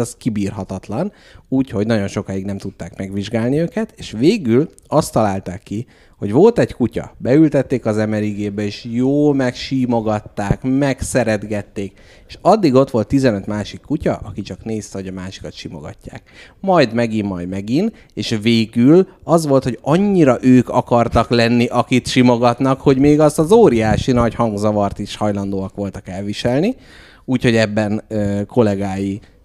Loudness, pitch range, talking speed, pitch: -17 LUFS, 100-130 Hz, 140 wpm, 110 Hz